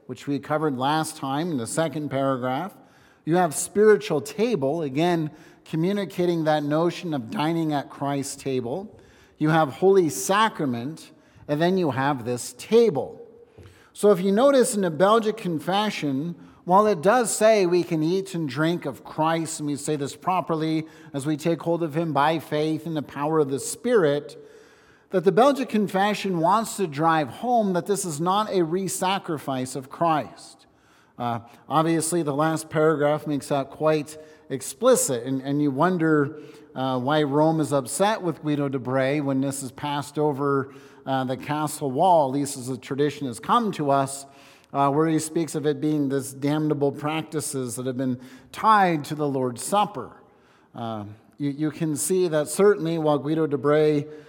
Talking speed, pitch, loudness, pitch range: 170 wpm, 155 Hz, -24 LUFS, 140-175 Hz